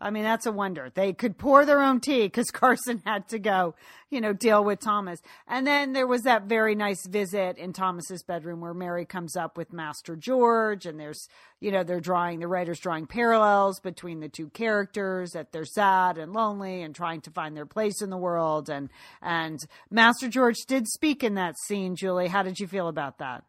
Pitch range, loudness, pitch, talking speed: 170-220 Hz, -26 LUFS, 190 Hz, 210 wpm